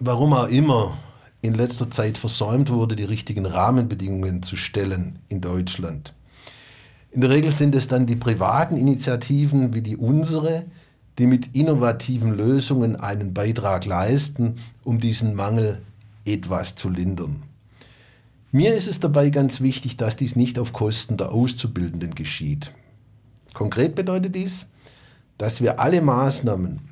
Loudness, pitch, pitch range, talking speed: -22 LUFS, 120 Hz, 105-135 Hz, 135 wpm